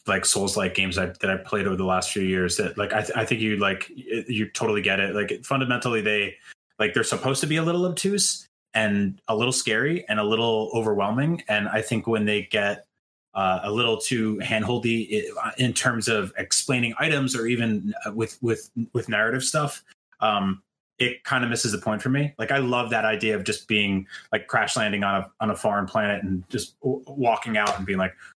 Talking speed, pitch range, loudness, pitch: 220 wpm, 100-125 Hz, -24 LUFS, 110 Hz